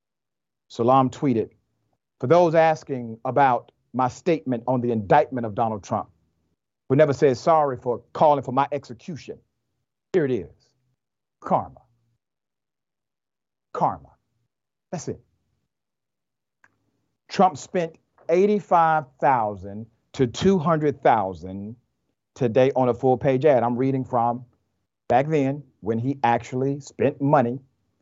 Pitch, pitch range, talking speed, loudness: 130 Hz, 115-145 Hz, 110 wpm, -22 LUFS